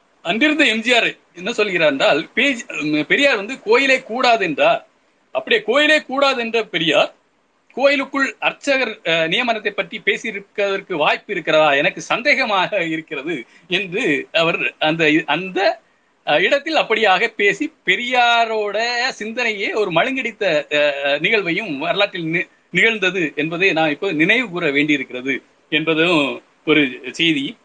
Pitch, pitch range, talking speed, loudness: 225 Hz, 165-280 Hz, 100 wpm, -17 LUFS